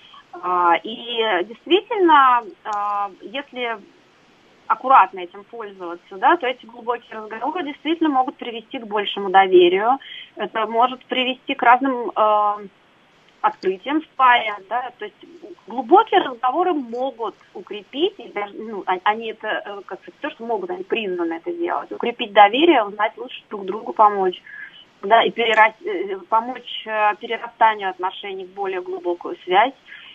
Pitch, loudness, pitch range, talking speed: 235 Hz, -19 LUFS, 205-305 Hz, 125 wpm